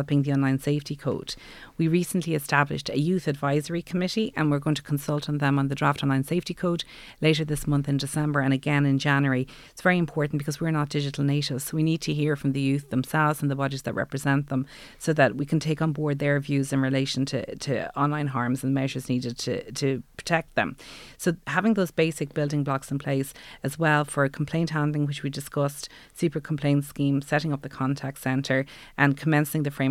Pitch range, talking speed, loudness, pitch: 135-155 Hz, 215 wpm, -26 LUFS, 145 Hz